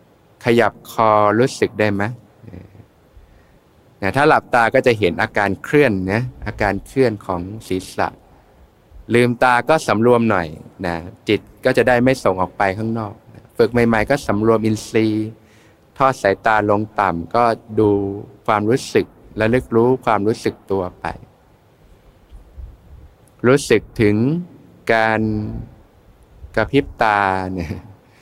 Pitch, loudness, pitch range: 110 Hz, -18 LUFS, 100-120 Hz